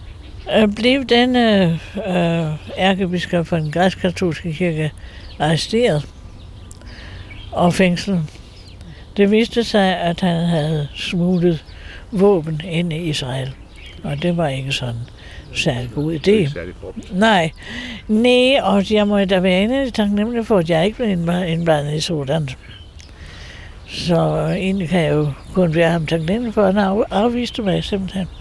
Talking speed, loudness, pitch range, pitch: 135 wpm, -18 LUFS, 145-195 Hz, 170 Hz